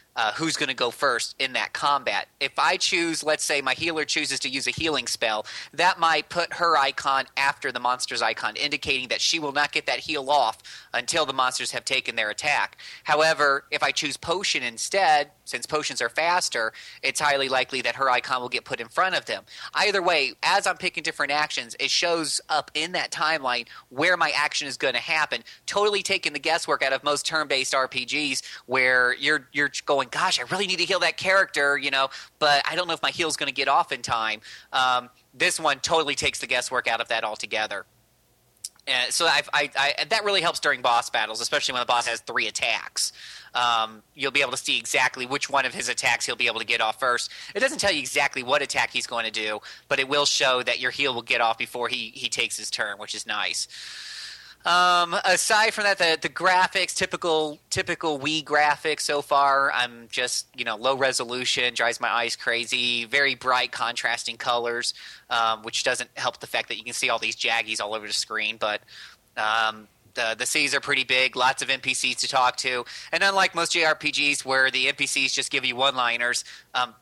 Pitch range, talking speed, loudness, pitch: 125-155 Hz, 215 wpm, -23 LUFS, 135 Hz